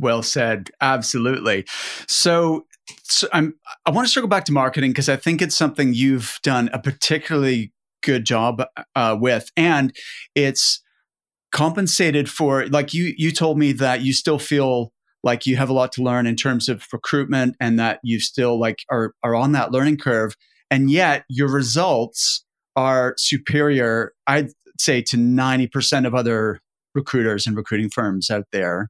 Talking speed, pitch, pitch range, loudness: 165 wpm, 130 Hz, 120-145 Hz, -19 LUFS